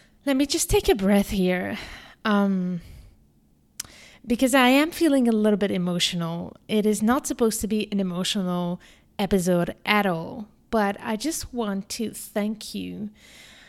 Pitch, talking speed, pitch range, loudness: 210 Hz, 150 wpm, 180-230 Hz, -24 LUFS